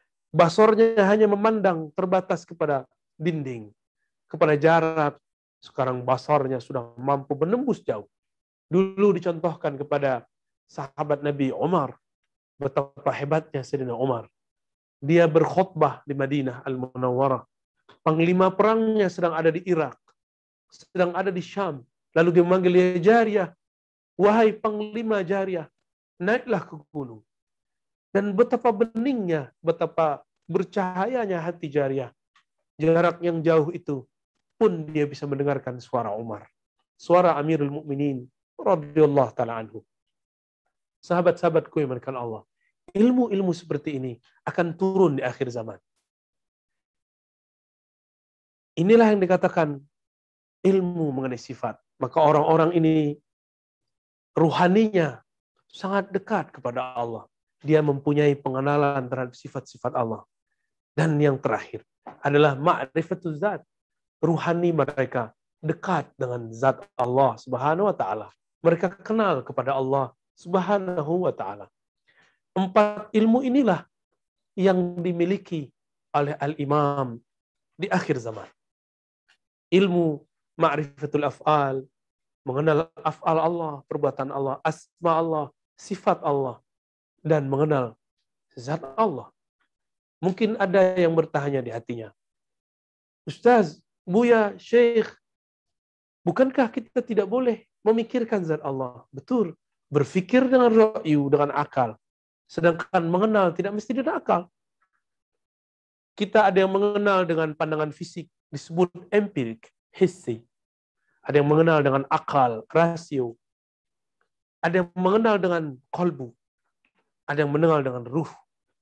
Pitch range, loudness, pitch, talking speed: 135-185 Hz, -24 LUFS, 155 Hz, 105 wpm